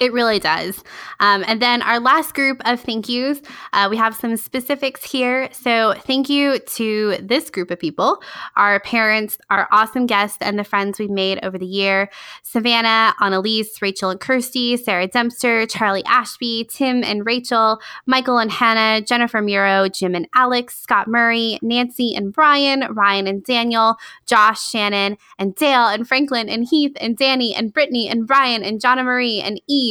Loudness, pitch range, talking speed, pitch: -17 LUFS, 205-250 Hz, 175 wpm, 230 Hz